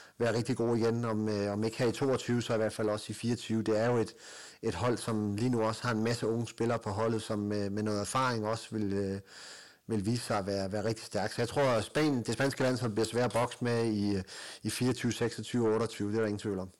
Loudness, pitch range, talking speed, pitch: -32 LUFS, 105-120 Hz, 270 wpm, 115 Hz